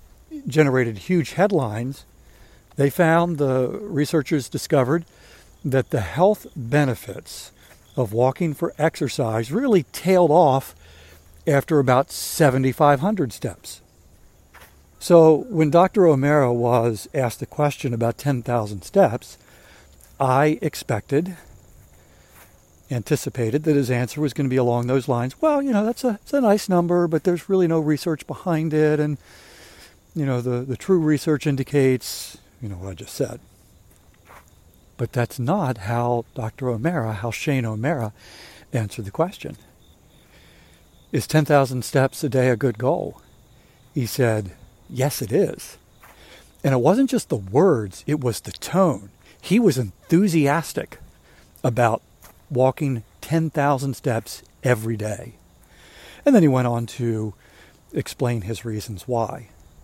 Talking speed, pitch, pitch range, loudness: 135 wpm, 130 Hz, 110-155 Hz, -21 LUFS